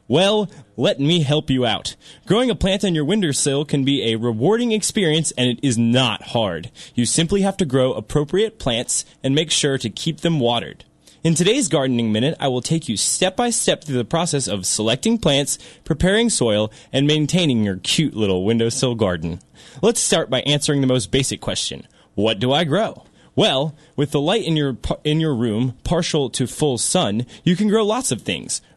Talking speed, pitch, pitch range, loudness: 195 wpm, 145 Hz, 125-165 Hz, -19 LUFS